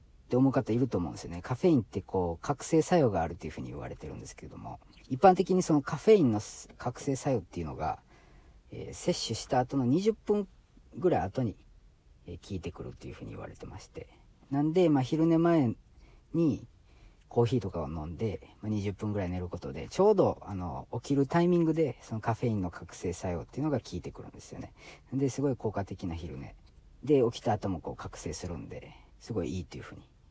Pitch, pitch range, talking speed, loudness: 115 Hz, 90-145 Hz, 420 characters per minute, -30 LUFS